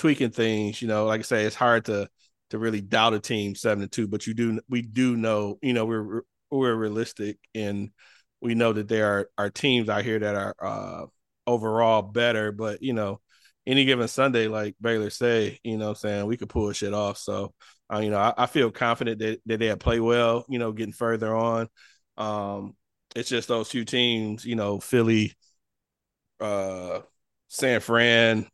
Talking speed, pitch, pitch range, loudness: 190 wpm, 110 Hz, 105-115 Hz, -25 LUFS